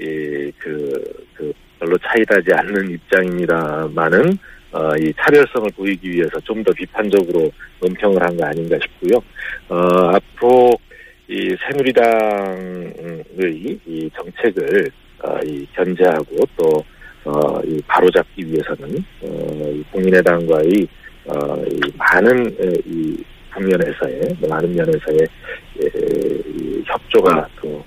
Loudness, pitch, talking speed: -17 LUFS, 105 Hz, 235 characters per minute